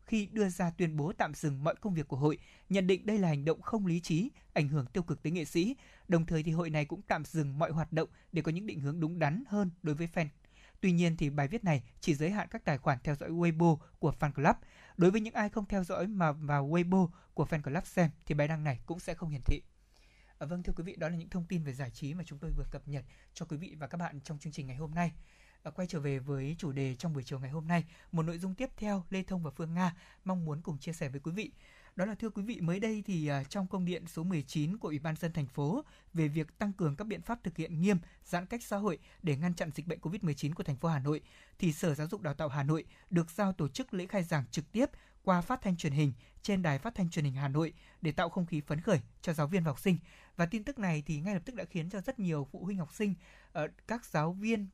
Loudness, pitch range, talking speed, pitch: -35 LUFS, 150-190 Hz, 285 wpm, 165 Hz